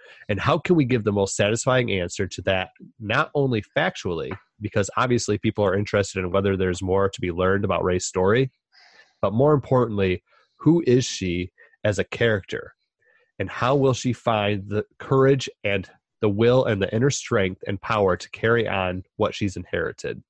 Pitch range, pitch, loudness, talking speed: 95-130 Hz, 105 Hz, -23 LUFS, 175 wpm